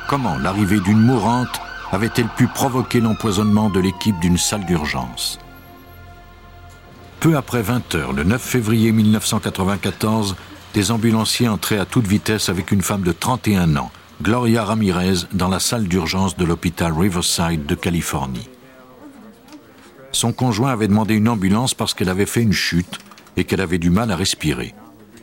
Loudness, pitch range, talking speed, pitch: -18 LUFS, 90-115 Hz, 145 wpm, 105 Hz